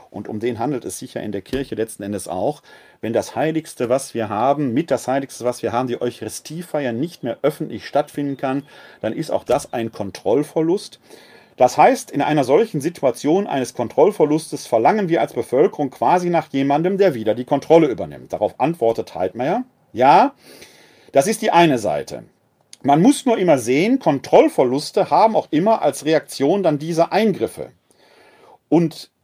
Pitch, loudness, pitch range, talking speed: 145 Hz, -19 LUFS, 120-165 Hz, 170 wpm